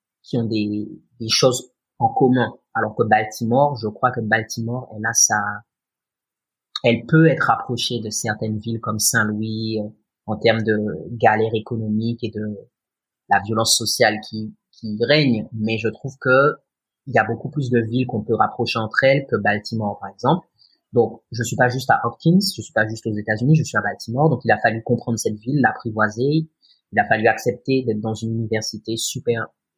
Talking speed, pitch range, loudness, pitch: 190 wpm, 110-125 Hz, -20 LUFS, 115 Hz